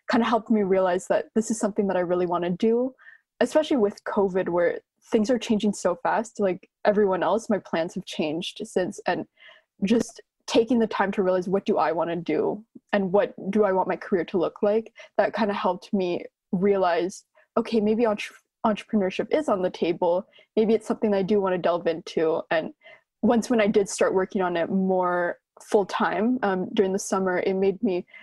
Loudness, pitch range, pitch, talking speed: -25 LUFS, 185-225 Hz, 205 Hz, 205 wpm